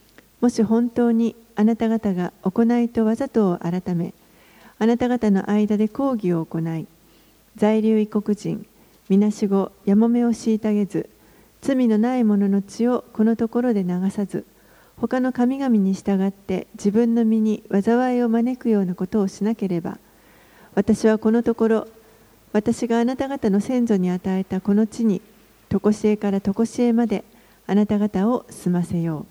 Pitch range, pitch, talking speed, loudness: 200-230 Hz, 215 Hz, 285 characters per minute, -21 LUFS